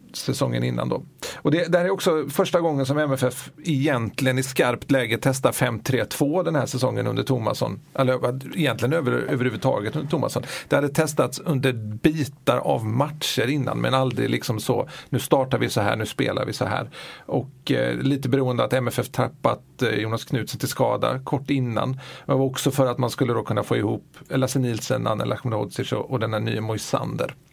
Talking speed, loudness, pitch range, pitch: 185 wpm, -24 LUFS, 120-145 Hz, 130 Hz